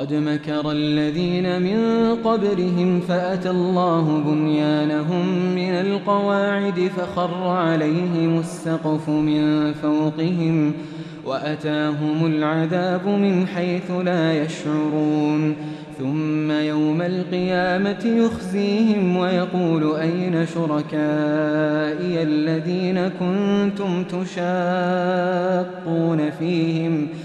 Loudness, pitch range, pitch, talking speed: -21 LUFS, 155-180 Hz, 170 Hz, 70 wpm